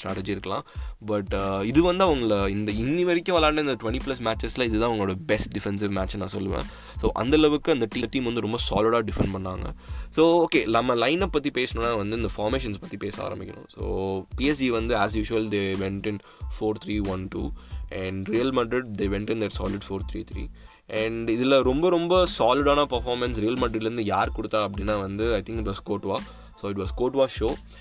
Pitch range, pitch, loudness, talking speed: 100-125 Hz, 110 Hz, -25 LUFS, 190 wpm